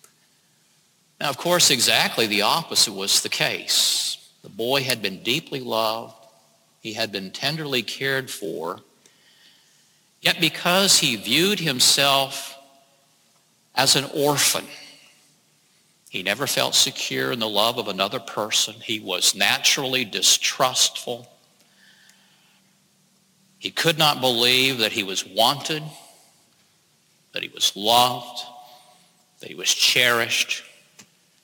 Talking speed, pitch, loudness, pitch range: 110 wpm, 135 Hz, -20 LUFS, 120-175 Hz